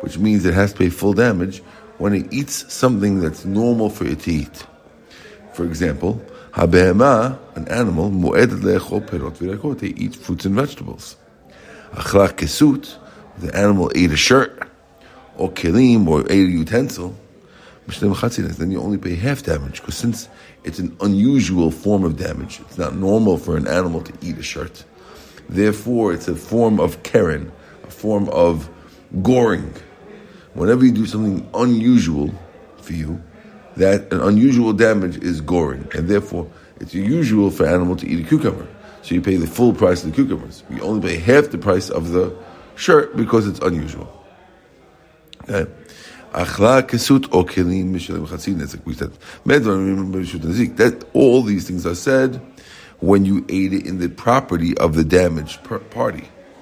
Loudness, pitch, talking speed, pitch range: -18 LUFS, 95 Hz, 140 wpm, 85-110 Hz